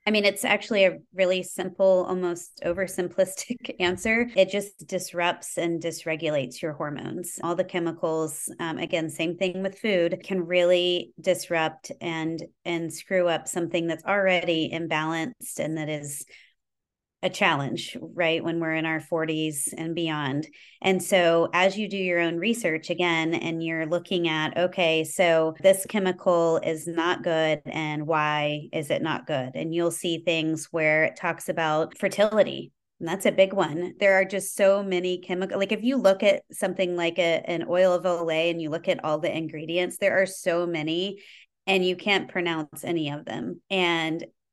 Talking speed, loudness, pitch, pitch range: 170 wpm, -25 LUFS, 175 Hz, 160-190 Hz